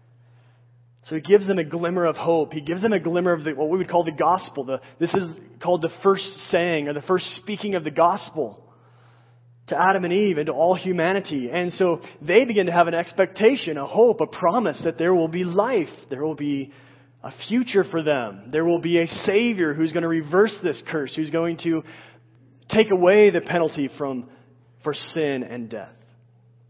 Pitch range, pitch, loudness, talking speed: 135-180 Hz, 165 Hz, -22 LUFS, 200 wpm